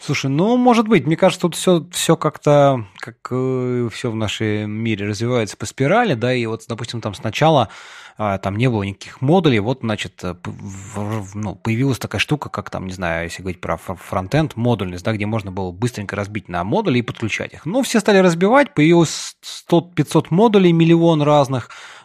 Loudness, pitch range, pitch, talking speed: -18 LUFS, 105-155 Hz, 120 Hz, 190 wpm